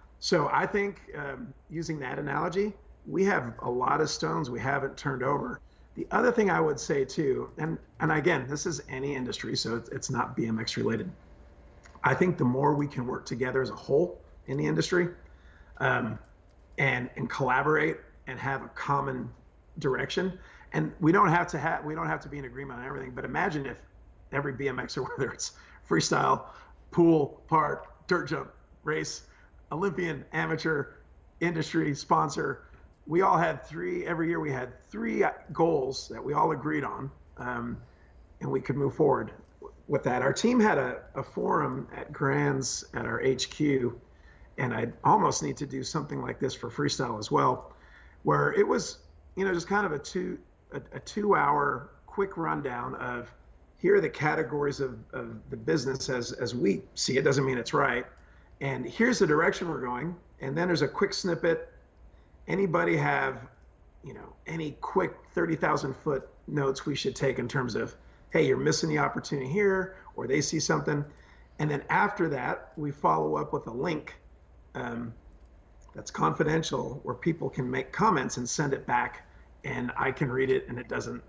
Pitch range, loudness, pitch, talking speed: 130-175 Hz, -29 LUFS, 145 Hz, 180 wpm